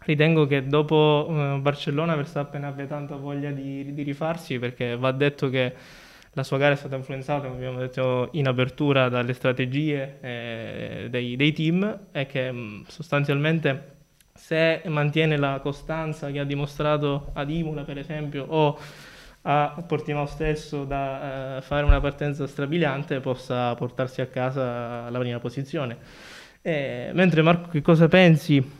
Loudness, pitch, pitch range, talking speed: -25 LUFS, 145 Hz, 130-150 Hz, 145 wpm